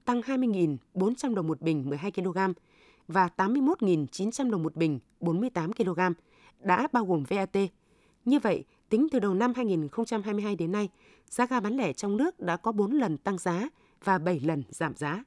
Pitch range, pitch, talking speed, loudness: 175-230 Hz, 195 Hz, 175 wpm, -29 LUFS